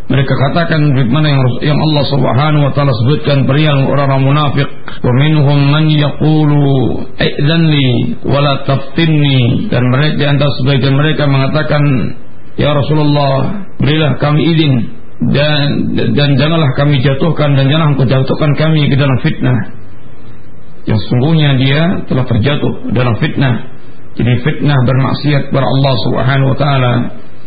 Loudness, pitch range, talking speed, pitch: -11 LUFS, 130-150 Hz, 130 wpm, 140 Hz